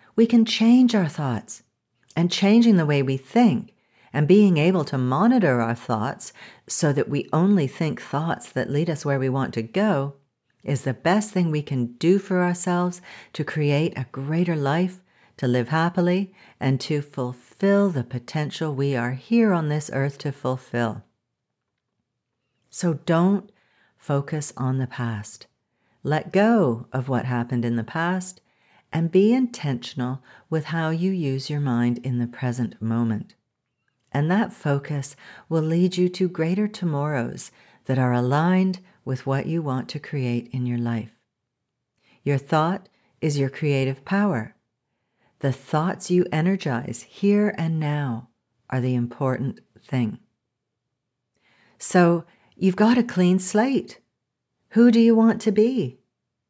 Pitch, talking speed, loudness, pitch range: 150 Hz, 150 wpm, -23 LUFS, 130-185 Hz